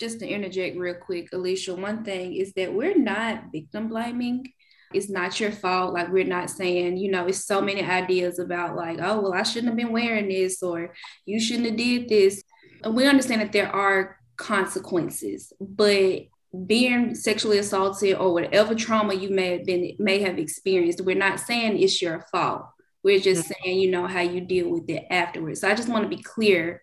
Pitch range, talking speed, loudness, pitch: 180-220 Hz, 200 wpm, -24 LUFS, 195 Hz